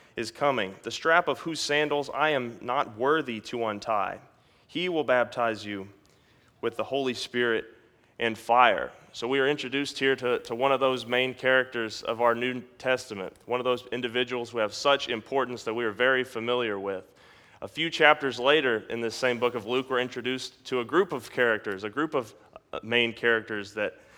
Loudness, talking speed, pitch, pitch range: -27 LUFS, 190 wpm, 125 Hz, 115-135 Hz